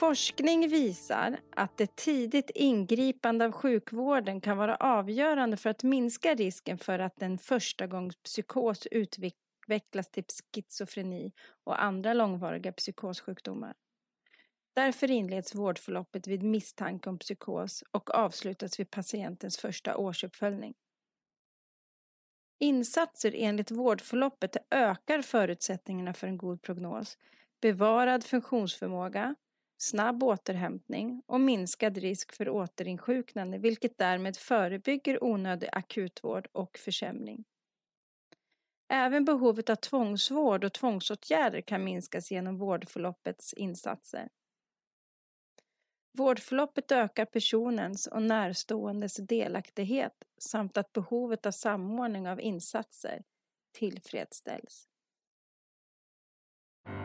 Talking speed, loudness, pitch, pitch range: 95 wpm, -32 LUFS, 215 Hz, 190-245 Hz